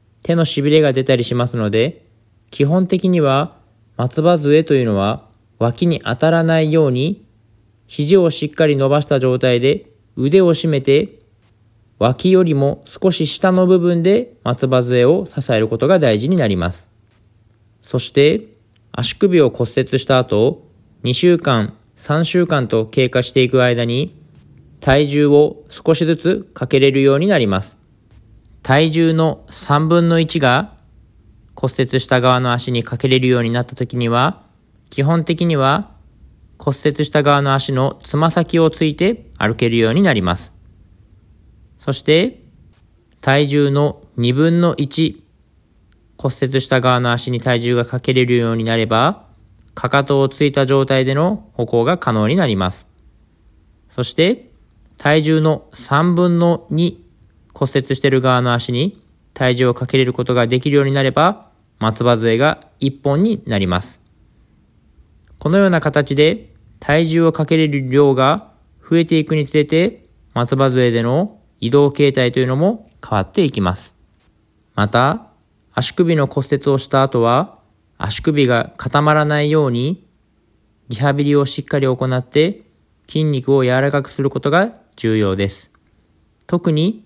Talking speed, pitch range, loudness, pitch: 260 characters per minute, 110-155 Hz, -16 LUFS, 130 Hz